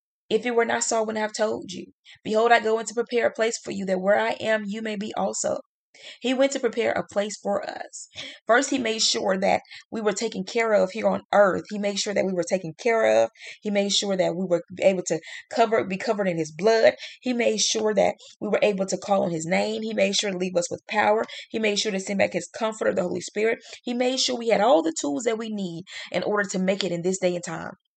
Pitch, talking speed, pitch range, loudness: 210 Hz, 265 wpm, 190-225 Hz, -24 LUFS